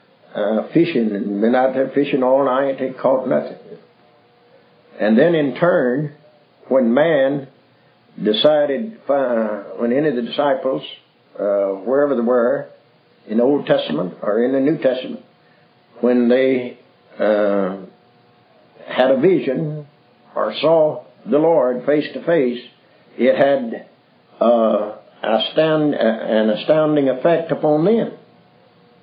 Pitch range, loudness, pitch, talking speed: 120-150 Hz, -18 LUFS, 130 Hz, 130 wpm